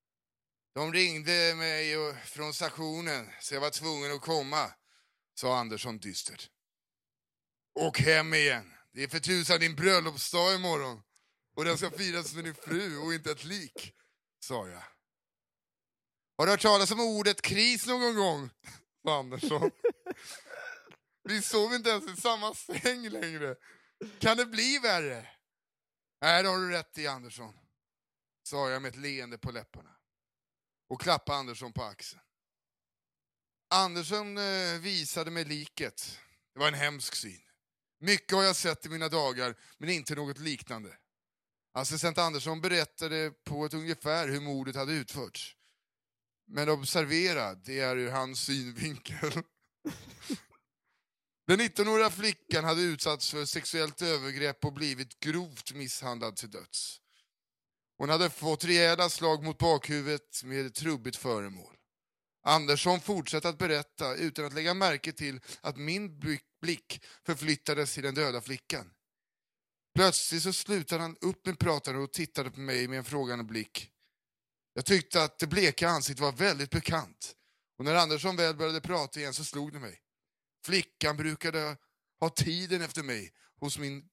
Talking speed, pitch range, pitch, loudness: 145 wpm, 140-175 Hz, 155 Hz, -31 LUFS